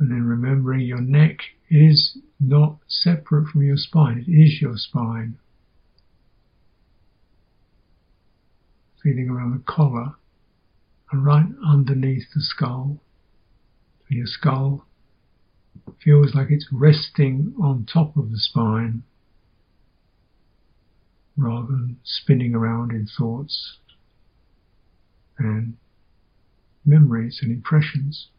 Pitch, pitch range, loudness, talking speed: 130 Hz, 110-145 Hz, -20 LUFS, 95 wpm